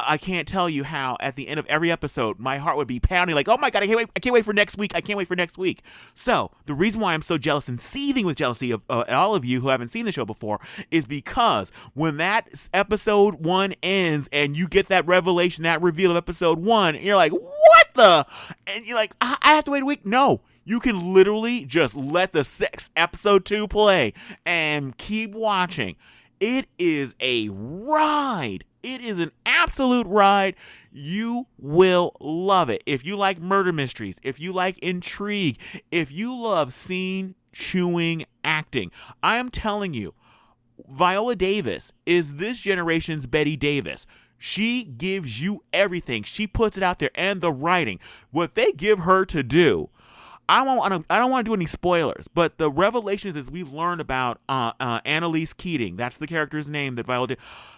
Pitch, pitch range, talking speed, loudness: 180 Hz, 150-205 Hz, 190 wpm, -22 LUFS